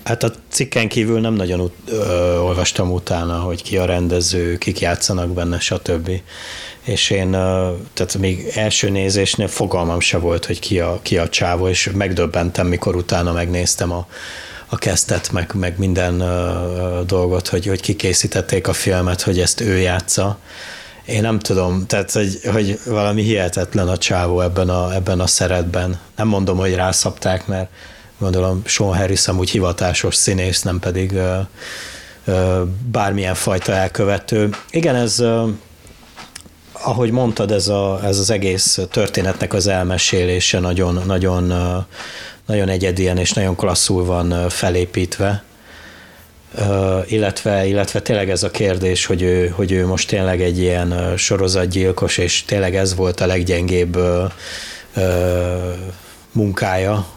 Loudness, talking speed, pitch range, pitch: -17 LUFS, 140 wpm, 90-100 Hz, 95 Hz